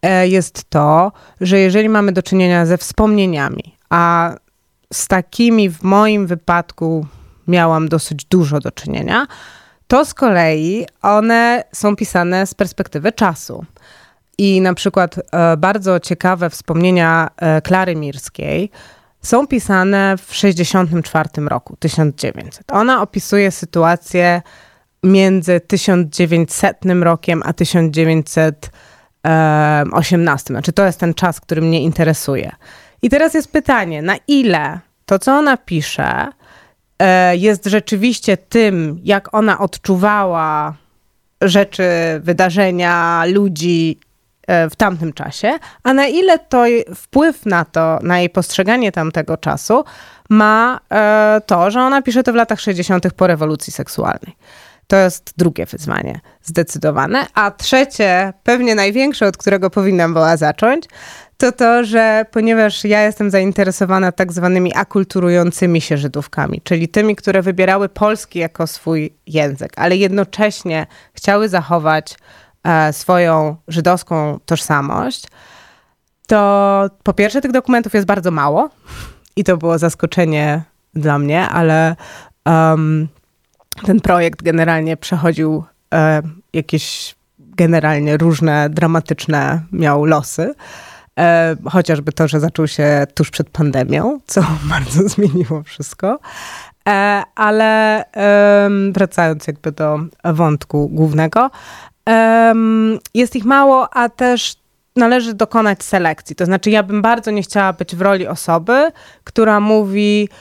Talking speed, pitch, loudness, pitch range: 120 wpm, 180 Hz, -14 LUFS, 160-210 Hz